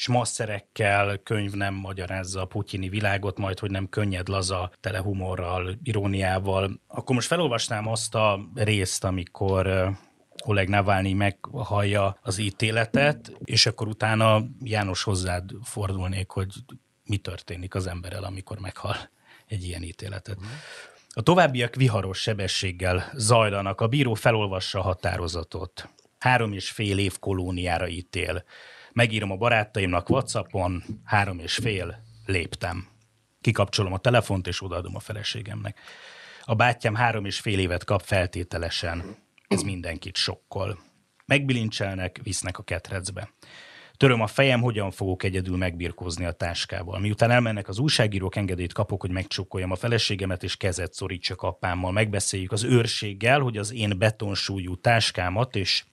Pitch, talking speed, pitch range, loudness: 100 Hz, 130 wpm, 95-110 Hz, -26 LUFS